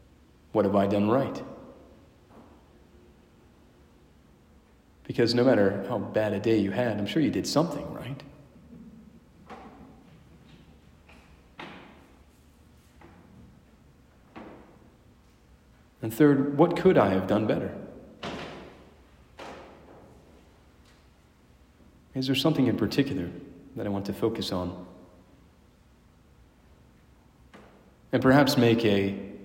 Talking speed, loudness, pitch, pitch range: 90 wpm, -26 LUFS, 100 Hz, 75-120 Hz